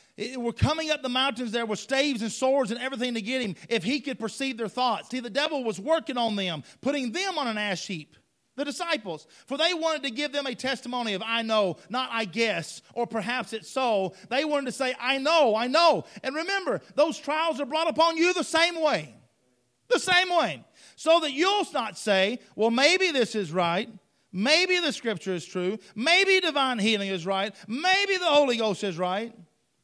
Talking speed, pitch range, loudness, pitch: 205 wpm, 210-300 Hz, -26 LUFS, 250 Hz